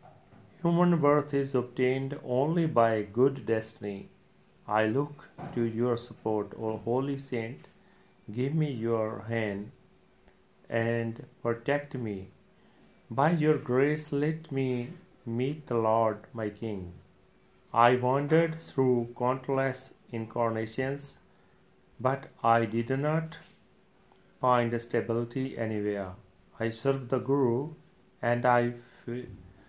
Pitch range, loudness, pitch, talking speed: 115-140 Hz, -30 LUFS, 125 Hz, 105 wpm